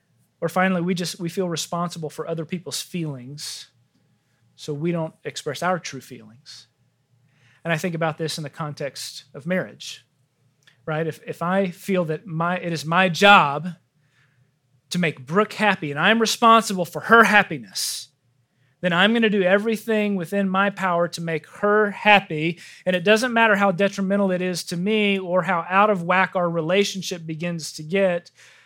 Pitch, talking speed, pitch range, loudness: 175 Hz, 175 wpm, 145-195 Hz, -21 LUFS